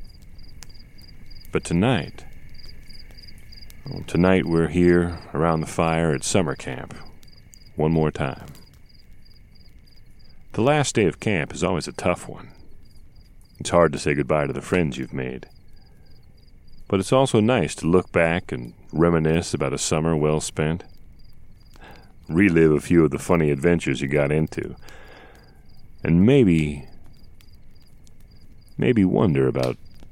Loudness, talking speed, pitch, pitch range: -21 LUFS, 130 wpm, 80 Hz, 75-90 Hz